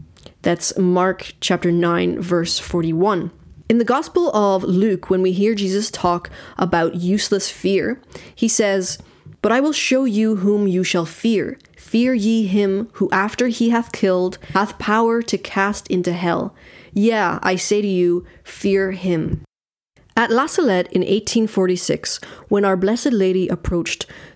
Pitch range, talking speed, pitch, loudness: 180-220 Hz, 150 wpm, 195 Hz, -19 LUFS